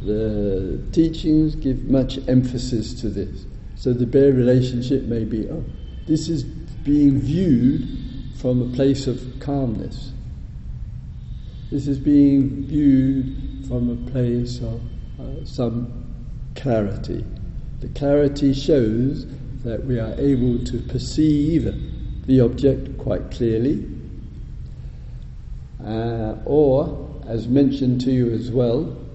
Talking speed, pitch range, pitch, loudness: 115 wpm, 120-140 Hz, 130 Hz, -21 LUFS